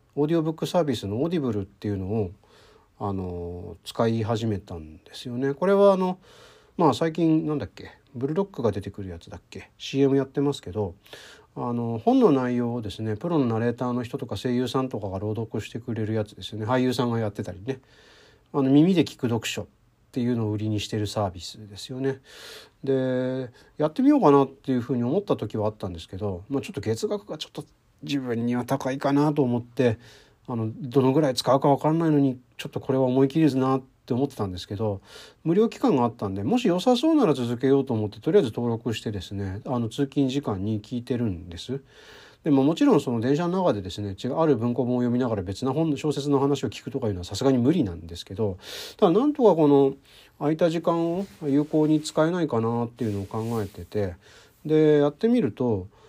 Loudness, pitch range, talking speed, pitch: -25 LUFS, 110-145 Hz, 430 characters per minute, 125 Hz